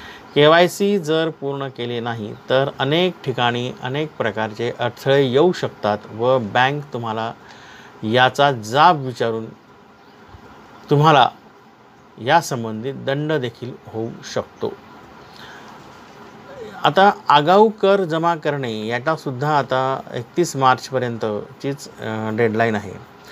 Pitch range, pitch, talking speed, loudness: 115-150 Hz, 130 Hz, 95 wpm, -19 LUFS